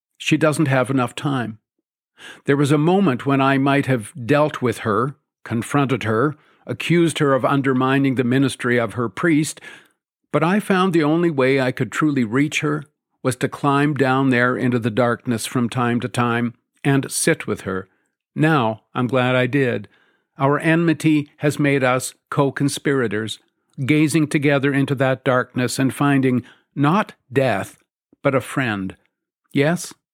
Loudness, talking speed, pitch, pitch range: -19 LUFS, 155 wpm, 135 Hz, 125-150 Hz